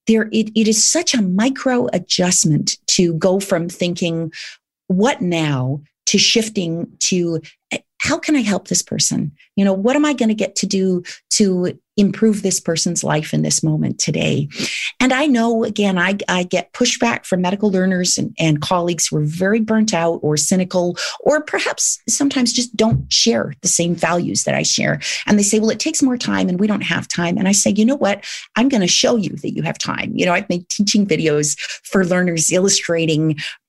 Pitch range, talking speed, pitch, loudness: 175-220 Hz, 200 wpm, 190 Hz, -17 LUFS